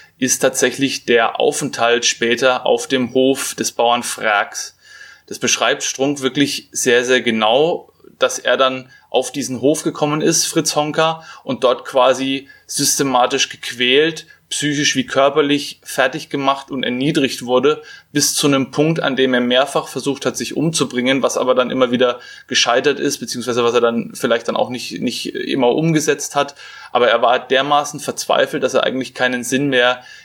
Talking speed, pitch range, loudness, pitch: 165 wpm, 125-145 Hz, -16 LUFS, 135 Hz